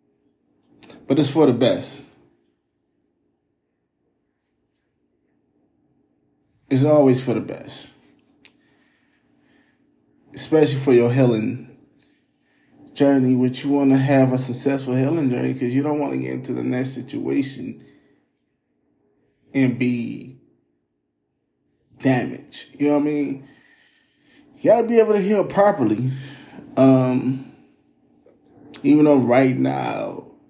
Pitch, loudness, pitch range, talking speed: 135 Hz, -19 LUFS, 125-145 Hz, 110 wpm